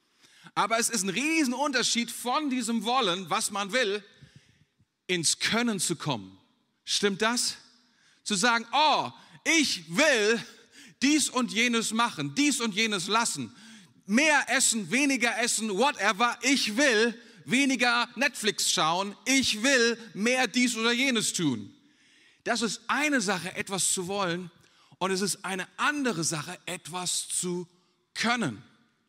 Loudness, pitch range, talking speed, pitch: -26 LUFS, 185-245 Hz, 130 wpm, 225 Hz